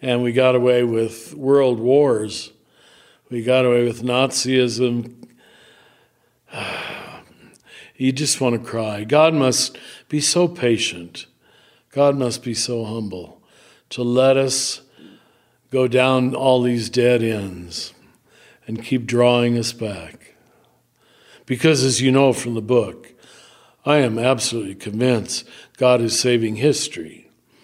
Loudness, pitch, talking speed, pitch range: -19 LUFS, 125 Hz, 120 wpm, 115-130 Hz